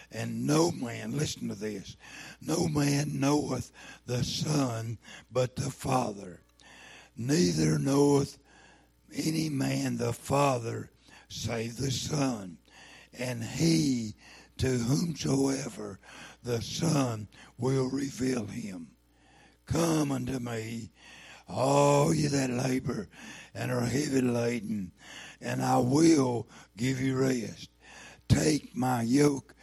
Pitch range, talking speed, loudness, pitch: 115-140 Hz, 105 wpm, -29 LUFS, 130 Hz